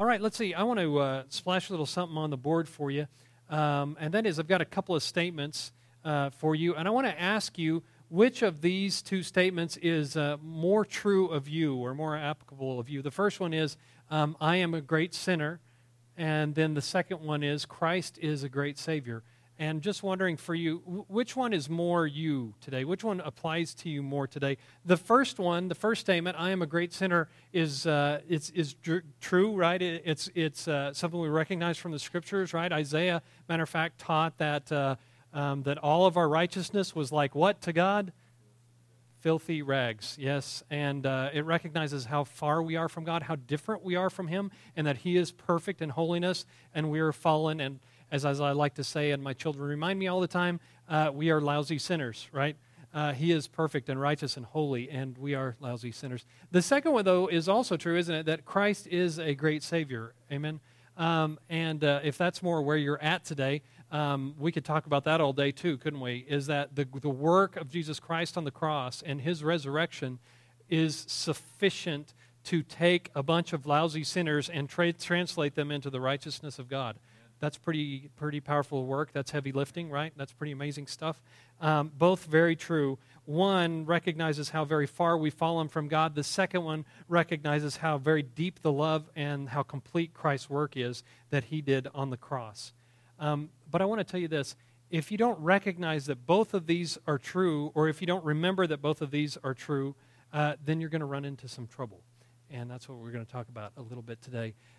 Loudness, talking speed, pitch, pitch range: -31 LUFS, 210 wpm, 155 Hz, 140-170 Hz